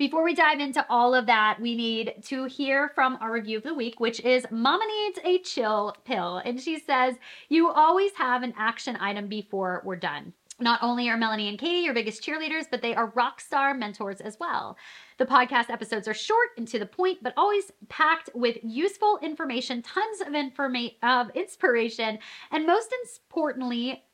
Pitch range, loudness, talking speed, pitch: 230-315 Hz, -26 LUFS, 190 wpm, 250 Hz